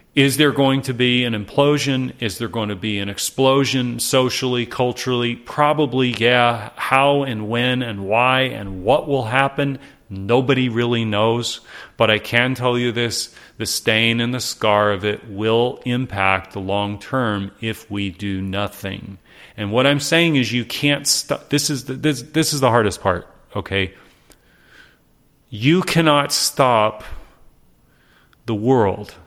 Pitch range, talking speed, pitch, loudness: 105-135 Hz, 155 wpm, 120 Hz, -18 LUFS